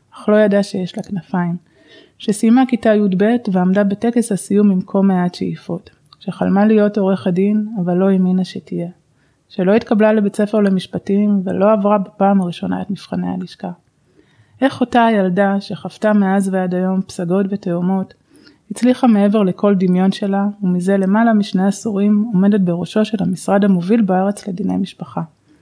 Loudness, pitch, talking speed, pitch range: -16 LUFS, 195 Hz, 150 wpm, 185-210 Hz